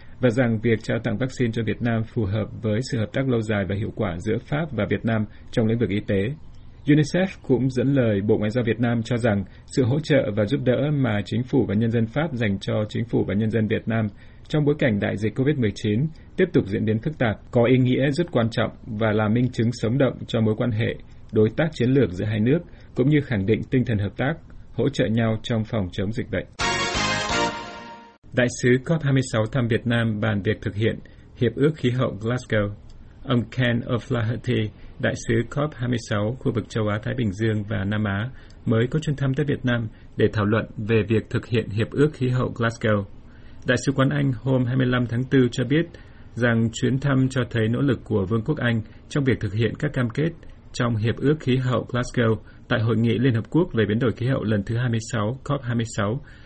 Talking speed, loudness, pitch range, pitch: 225 wpm, -23 LUFS, 110-130 Hz, 115 Hz